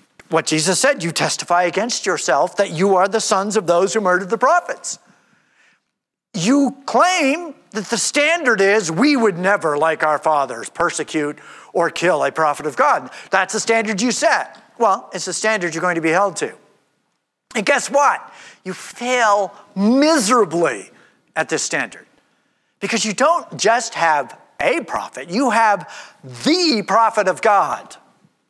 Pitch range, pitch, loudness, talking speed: 175-260 Hz, 210 Hz, -17 LUFS, 155 wpm